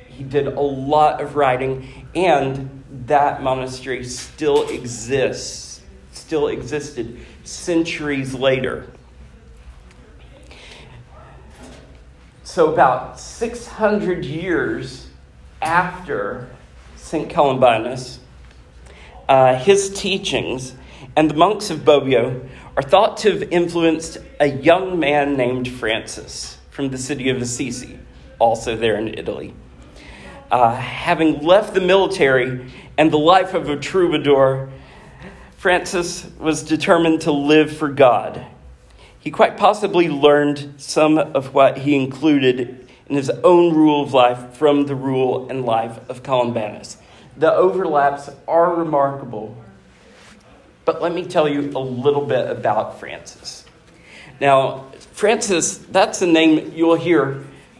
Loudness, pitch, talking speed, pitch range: -18 LUFS, 140 Hz, 115 wpm, 125-160 Hz